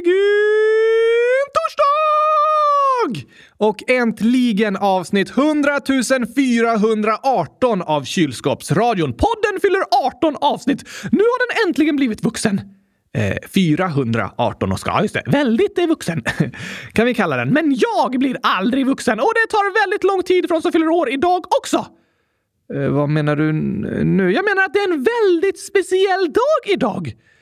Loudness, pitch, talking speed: -17 LUFS, 275 Hz, 145 wpm